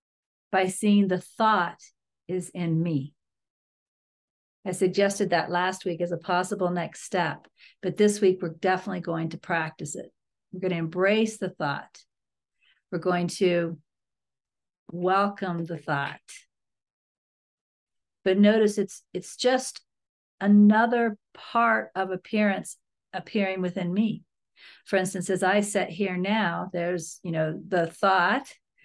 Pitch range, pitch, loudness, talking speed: 175-205 Hz, 185 Hz, -26 LUFS, 130 wpm